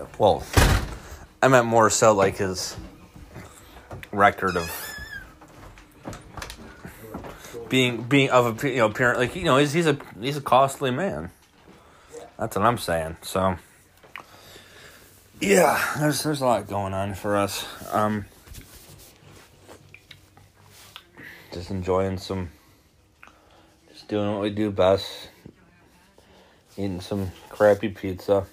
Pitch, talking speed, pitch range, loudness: 100 Hz, 115 wpm, 95-120 Hz, -23 LUFS